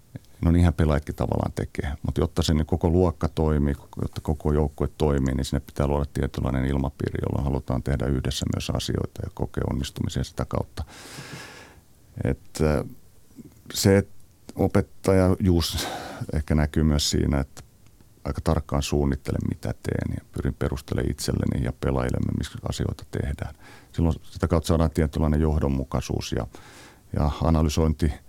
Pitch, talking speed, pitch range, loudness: 80 Hz, 140 wpm, 70-90 Hz, -26 LUFS